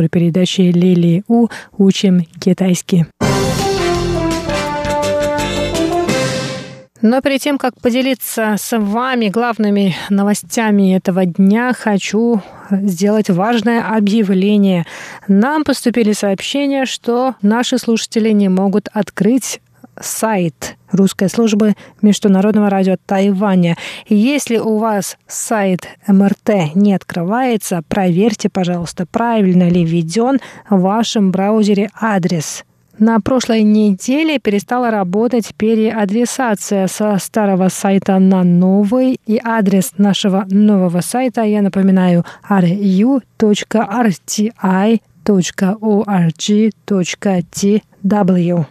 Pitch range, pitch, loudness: 190-225 Hz, 205 Hz, -14 LUFS